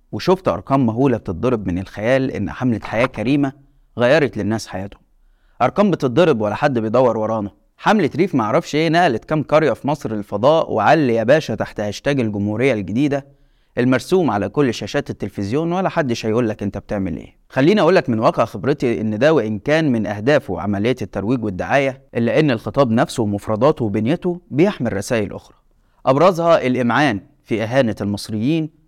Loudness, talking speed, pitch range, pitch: -18 LUFS, 160 wpm, 105-145 Hz, 120 Hz